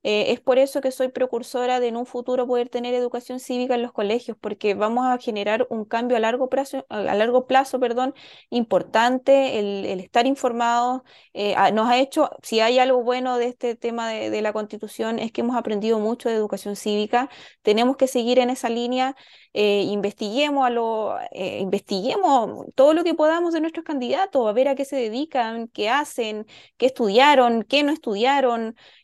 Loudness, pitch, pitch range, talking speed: -22 LUFS, 245 Hz, 225-260 Hz, 190 wpm